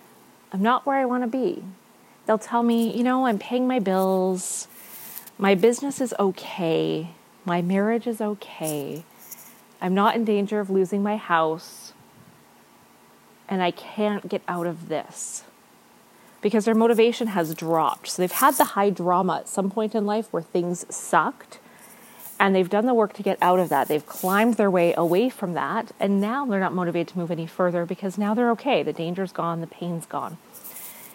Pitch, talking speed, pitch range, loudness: 200 Hz, 180 wpm, 175-230 Hz, -24 LUFS